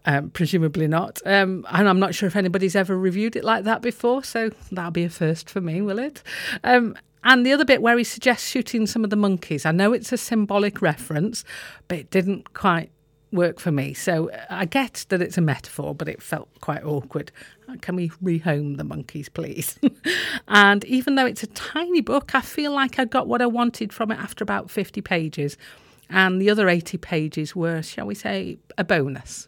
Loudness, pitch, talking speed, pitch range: -22 LUFS, 195 Hz, 205 wpm, 170-235 Hz